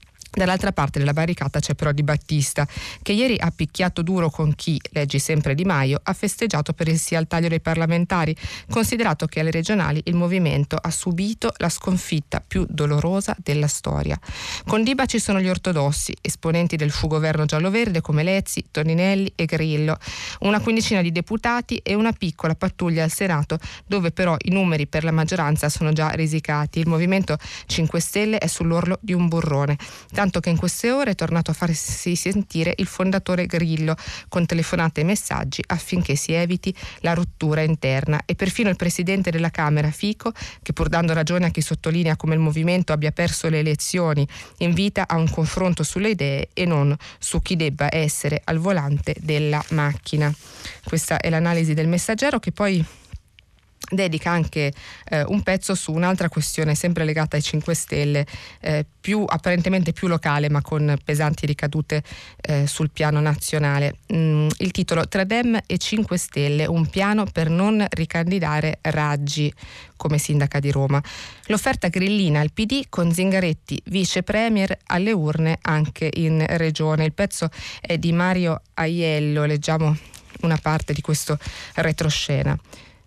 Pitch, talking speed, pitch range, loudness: 165 Hz, 160 wpm, 150-180 Hz, -22 LUFS